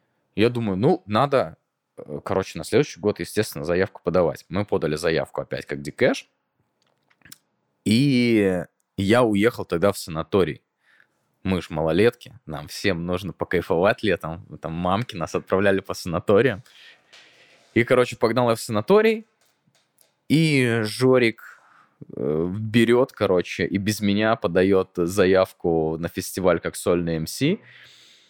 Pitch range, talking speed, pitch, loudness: 85-115 Hz, 120 wpm, 100 Hz, -22 LUFS